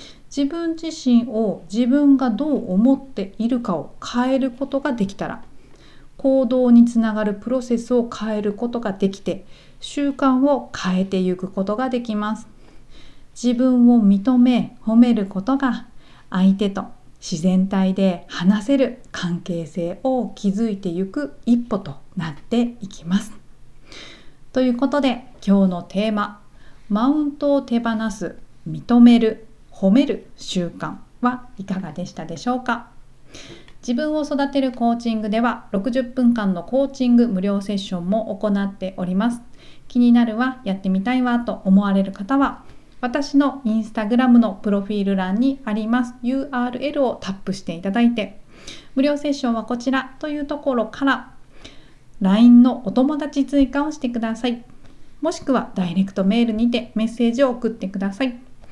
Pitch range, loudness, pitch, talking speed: 200-255 Hz, -20 LUFS, 235 Hz, 305 characters per minute